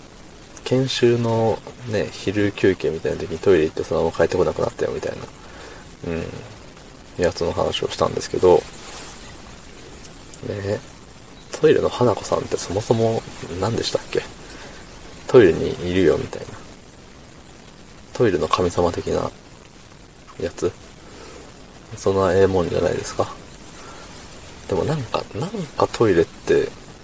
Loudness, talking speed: -21 LUFS, 270 characters per minute